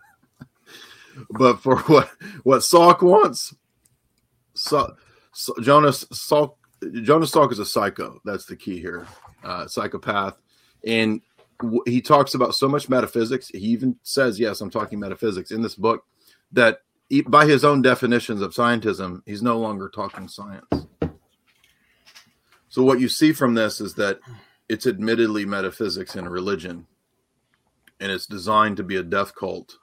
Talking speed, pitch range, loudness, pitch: 145 wpm, 110-135 Hz, -20 LUFS, 120 Hz